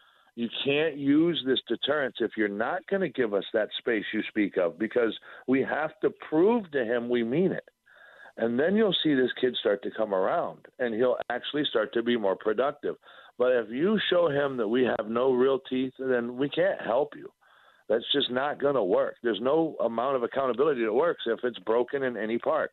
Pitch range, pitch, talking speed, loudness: 120-165 Hz, 130 Hz, 210 wpm, -27 LUFS